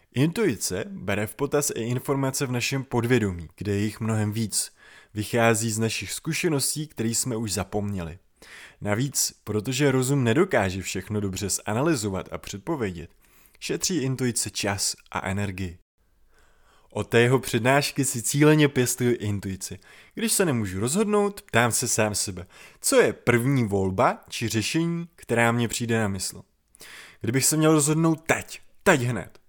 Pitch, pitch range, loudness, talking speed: 115 Hz, 100-140 Hz, -24 LUFS, 140 wpm